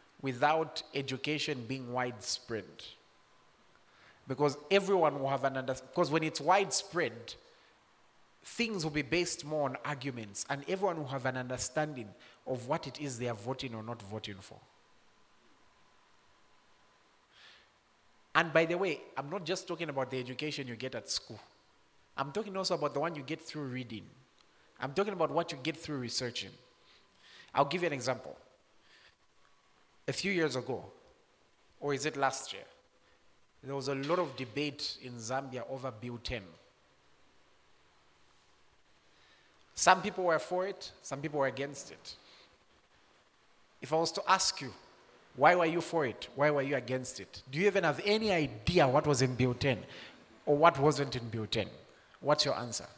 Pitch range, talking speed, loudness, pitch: 125-160 Hz, 160 wpm, -33 LUFS, 140 Hz